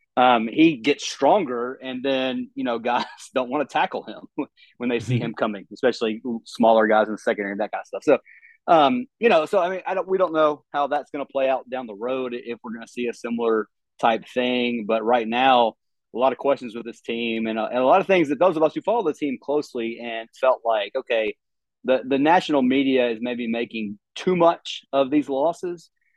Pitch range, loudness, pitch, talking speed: 115-165 Hz, -22 LUFS, 130 Hz, 235 wpm